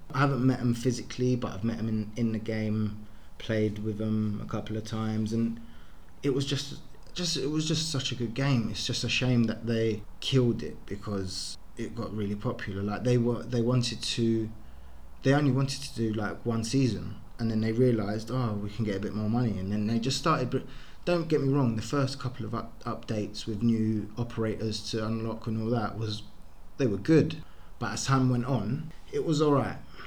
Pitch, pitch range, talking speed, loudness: 115 Hz, 105-125 Hz, 215 wpm, -30 LUFS